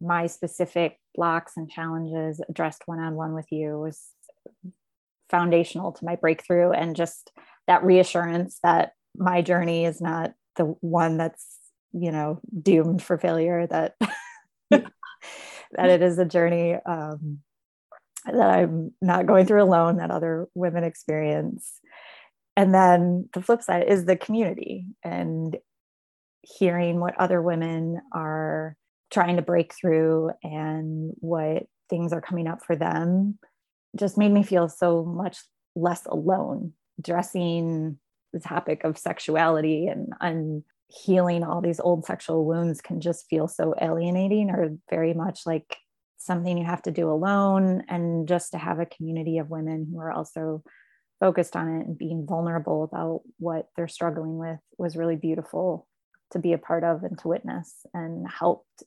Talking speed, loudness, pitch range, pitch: 150 wpm, -25 LUFS, 160-180 Hz, 170 Hz